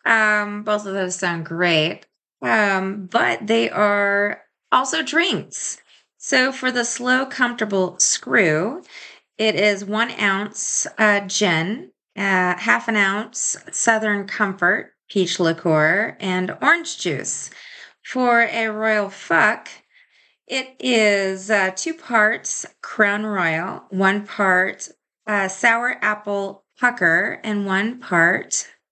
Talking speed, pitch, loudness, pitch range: 115 wpm, 210 Hz, -19 LUFS, 190-230 Hz